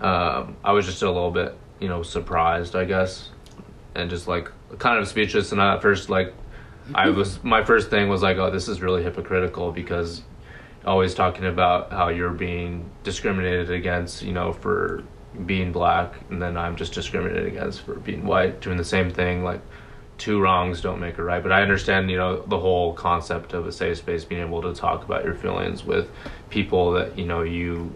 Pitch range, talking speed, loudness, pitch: 85-95 Hz, 200 wpm, -23 LUFS, 90 Hz